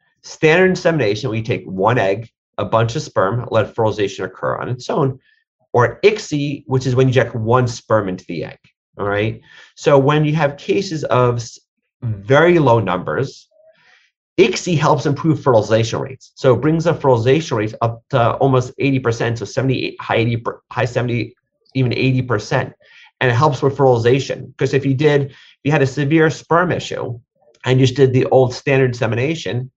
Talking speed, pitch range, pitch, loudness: 175 wpm, 120-145 Hz, 130 Hz, -17 LUFS